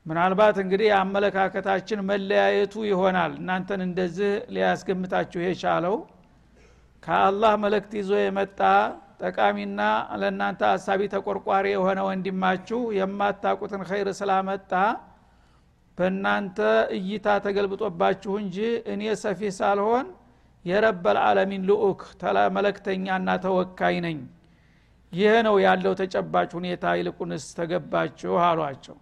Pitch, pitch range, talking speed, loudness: 195 Hz, 185-205 Hz, 90 wpm, -24 LUFS